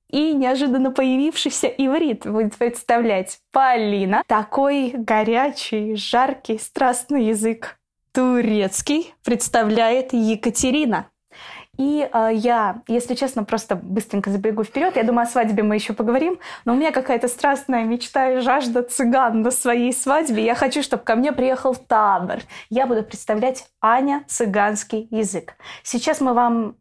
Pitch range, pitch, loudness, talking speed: 220-265 Hz, 245 Hz, -20 LUFS, 130 wpm